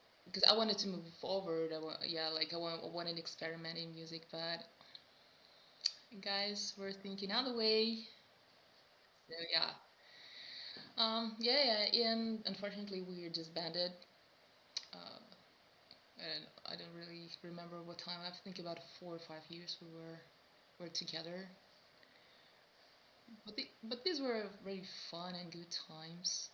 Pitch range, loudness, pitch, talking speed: 165-205 Hz, -40 LUFS, 175 Hz, 145 wpm